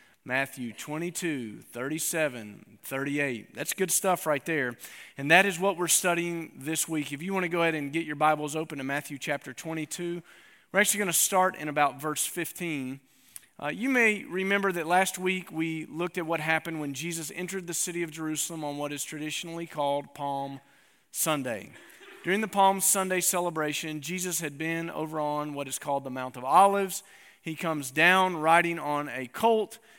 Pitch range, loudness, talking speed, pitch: 145-180 Hz, -28 LUFS, 180 wpm, 160 Hz